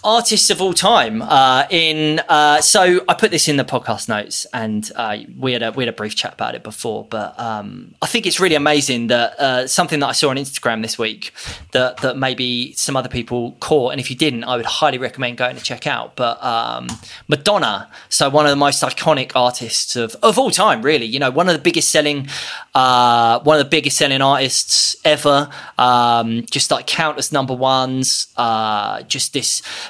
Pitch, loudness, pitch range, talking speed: 130 Hz, -16 LUFS, 125-155 Hz, 205 wpm